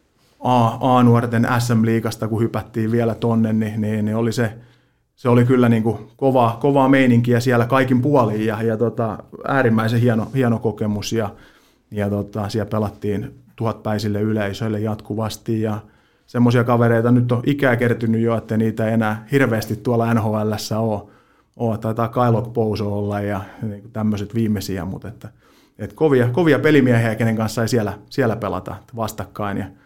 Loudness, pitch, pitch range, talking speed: -19 LUFS, 115 Hz, 105-120 Hz, 155 wpm